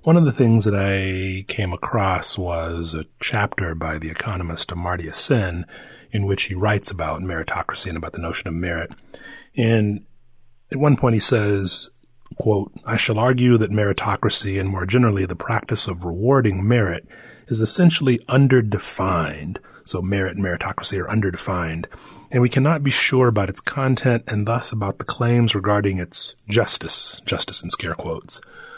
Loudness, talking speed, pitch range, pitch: -20 LUFS, 160 wpm, 90-120 Hz, 105 Hz